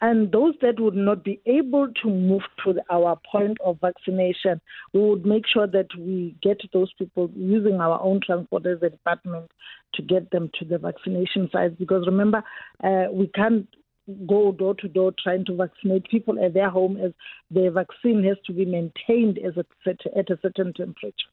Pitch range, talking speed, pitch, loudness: 180-205 Hz, 175 wpm, 190 Hz, -23 LUFS